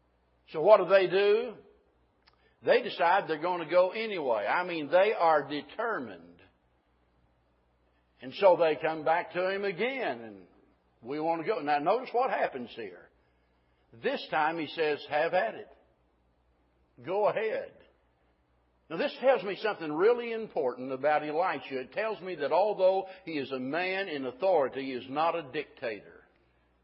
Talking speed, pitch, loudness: 155 wpm, 150 Hz, -29 LUFS